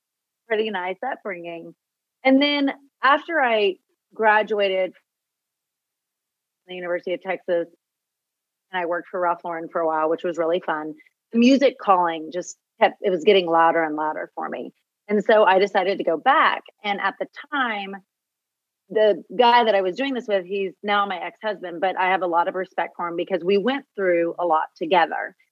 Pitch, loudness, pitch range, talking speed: 190 Hz, -22 LUFS, 175-215 Hz, 180 wpm